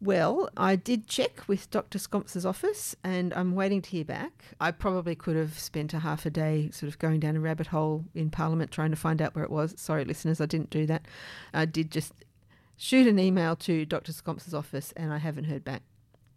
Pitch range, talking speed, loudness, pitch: 155-180 Hz, 220 wpm, -30 LUFS, 160 Hz